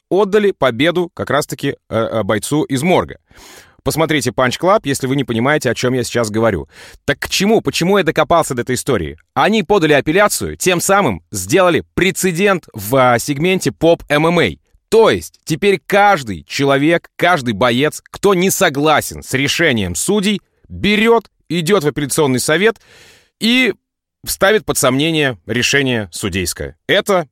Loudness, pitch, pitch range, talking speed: -15 LUFS, 150 Hz, 125-190 Hz, 135 wpm